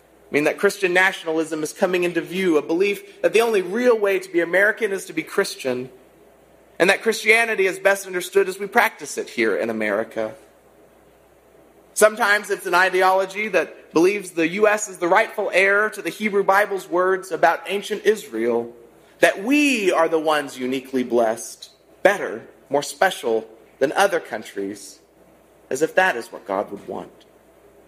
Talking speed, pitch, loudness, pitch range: 165 wpm, 190 Hz, -20 LUFS, 150-210 Hz